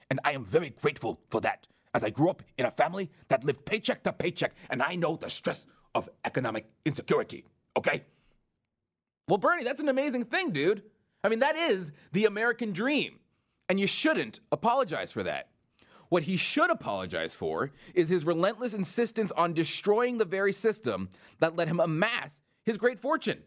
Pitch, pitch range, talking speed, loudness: 195 Hz, 165-240 Hz, 175 wpm, -30 LUFS